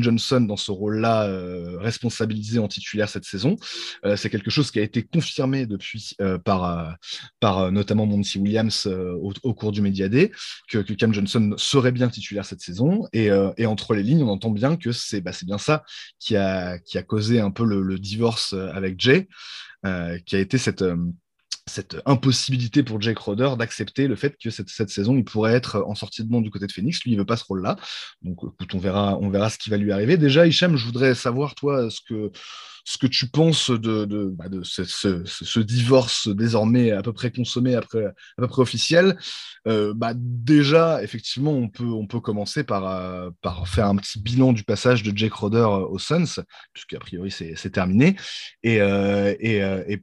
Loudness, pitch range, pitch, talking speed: -22 LUFS, 100-125 Hz, 110 Hz, 220 wpm